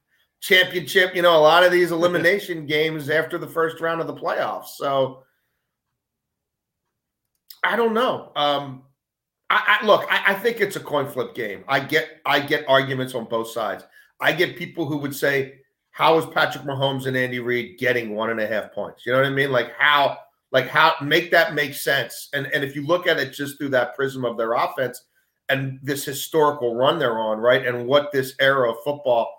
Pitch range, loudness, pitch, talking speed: 130-160 Hz, -21 LUFS, 145 Hz, 200 wpm